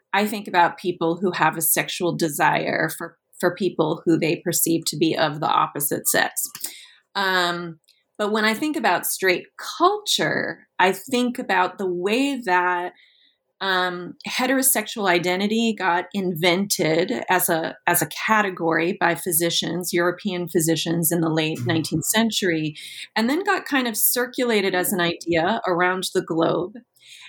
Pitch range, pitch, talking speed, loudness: 170-210 Hz, 180 Hz, 145 wpm, -21 LUFS